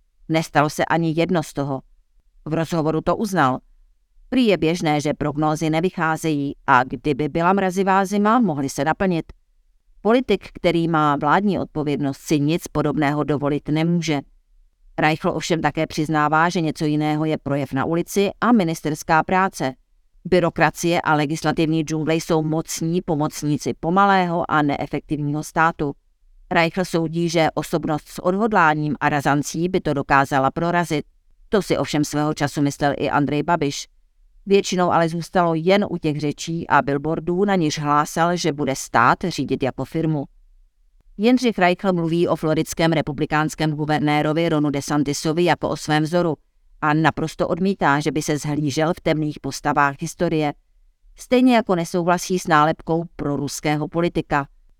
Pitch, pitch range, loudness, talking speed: 155 Hz, 145-170 Hz, -20 LUFS, 140 wpm